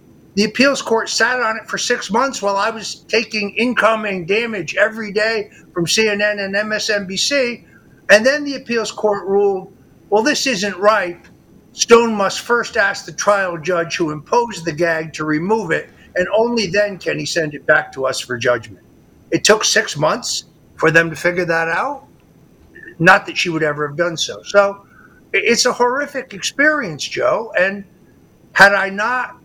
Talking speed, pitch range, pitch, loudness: 175 wpm, 175-225 Hz, 205 Hz, -16 LUFS